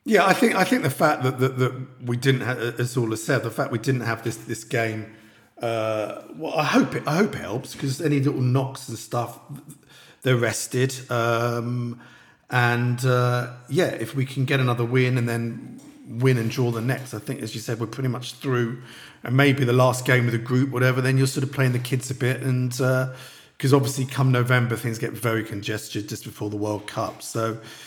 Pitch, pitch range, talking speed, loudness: 125 Hz, 115-135 Hz, 220 wpm, -24 LUFS